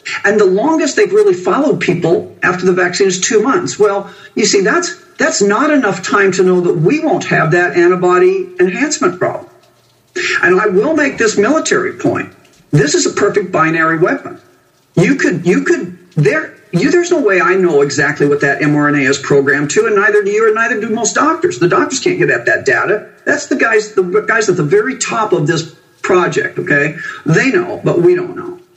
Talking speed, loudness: 200 wpm, -12 LUFS